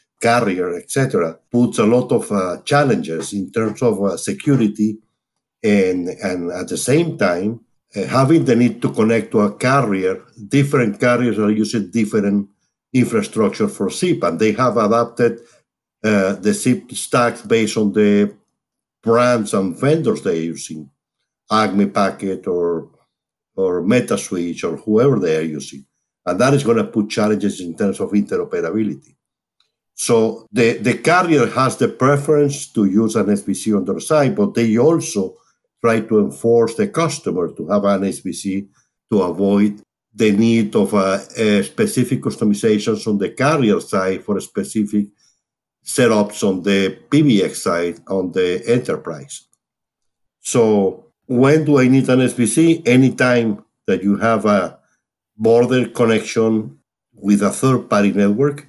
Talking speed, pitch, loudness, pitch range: 145 wpm, 110 Hz, -17 LUFS, 100-125 Hz